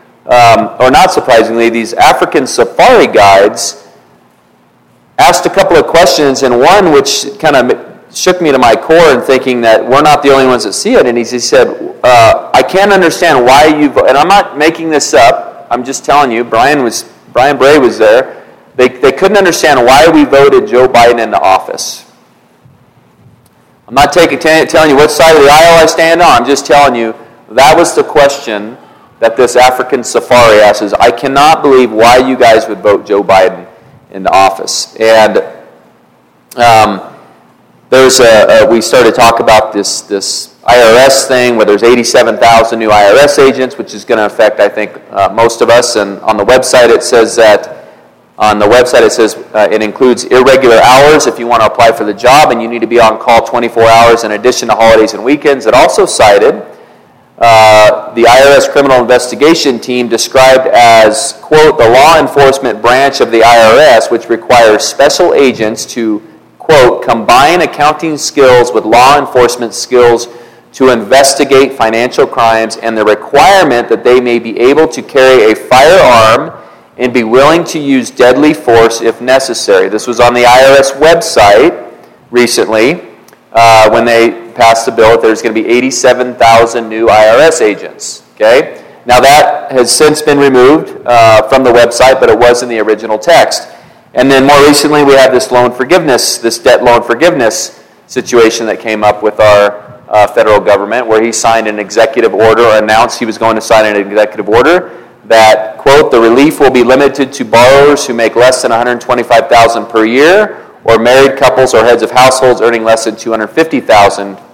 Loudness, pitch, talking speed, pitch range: -6 LUFS, 120 Hz, 180 wpm, 110-135 Hz